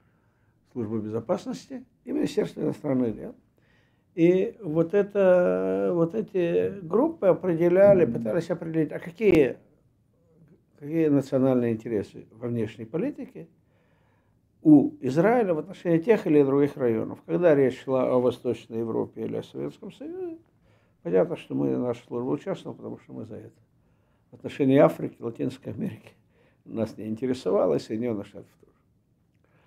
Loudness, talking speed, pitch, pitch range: -25 LUFS, 130 wpm, 145 Hz, 115-175 Hz